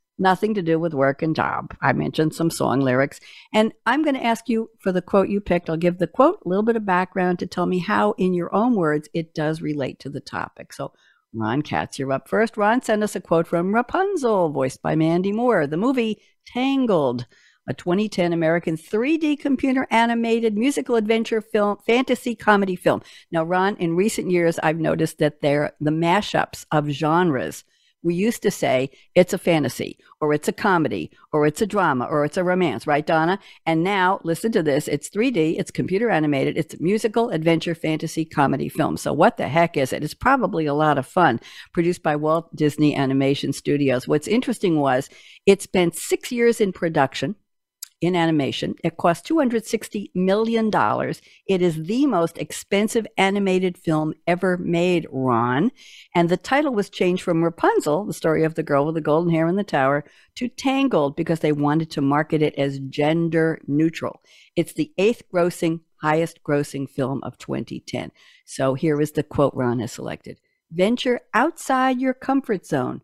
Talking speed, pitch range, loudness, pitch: 185 wpm, 150-210 Hz, -21 LUFS, 170 Hz